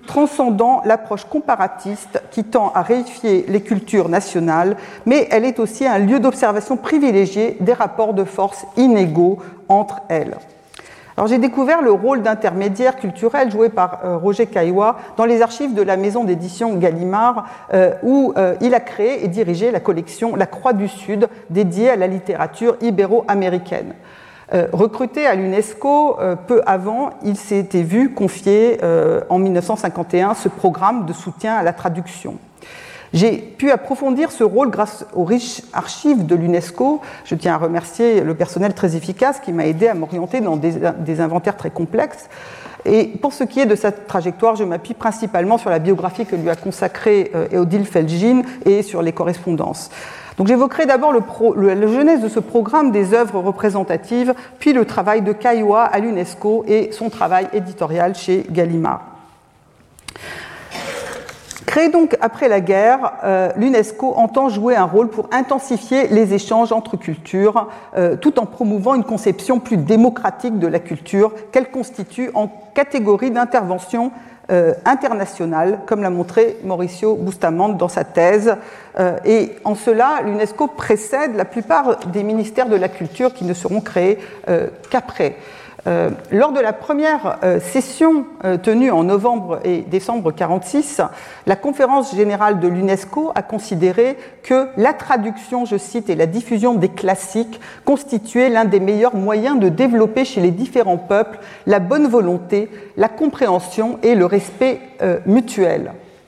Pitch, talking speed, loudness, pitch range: 215 Hz, 150 wpm, -17 LUFS, 190-245 Hz